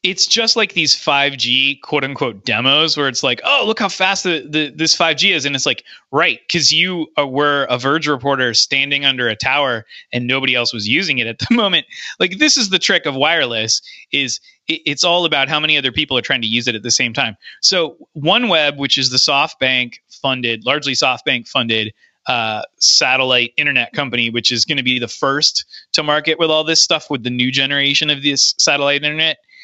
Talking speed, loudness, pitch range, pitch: 210 wpm, -14 LUFS, 125-160 Hz, 140 Hz